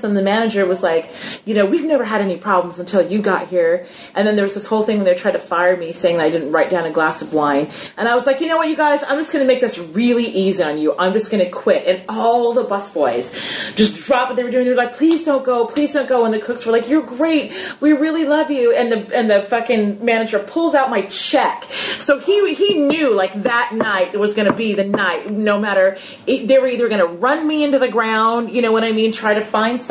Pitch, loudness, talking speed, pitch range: 225 Hz, -17 LUFS, 275 wpm, 195-260 Hz